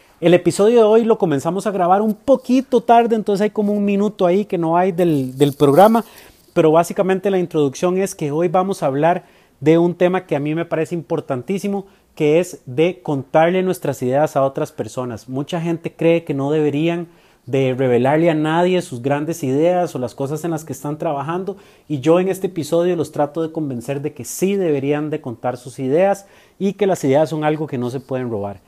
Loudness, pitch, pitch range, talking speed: -18 LUFS, 165 Hz, 145-185 Hz, 210 wpm